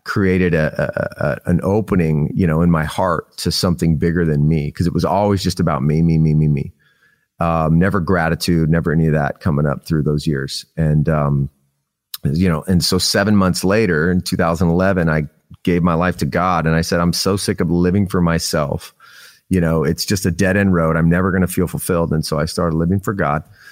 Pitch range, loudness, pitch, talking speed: 80-90 Hz, -17 LUFS, 85 Hz, 220 wpm